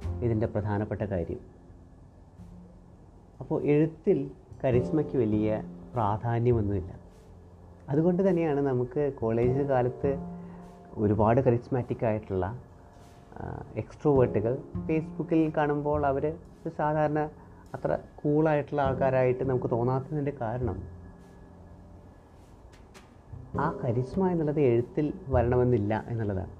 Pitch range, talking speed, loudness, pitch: 95-145 Hz, 75 wpm, -28 LUFS, 120 Hz